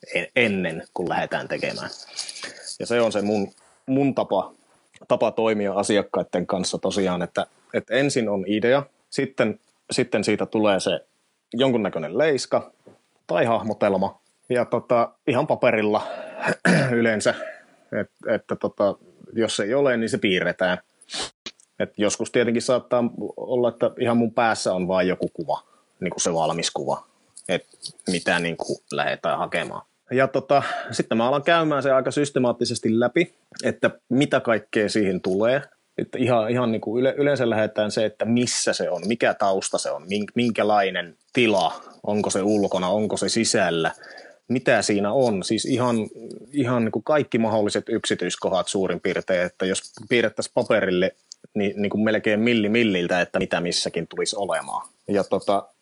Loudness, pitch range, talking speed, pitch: -23 LUFS, 100-125 Hz, 150 wpm, 110 Hz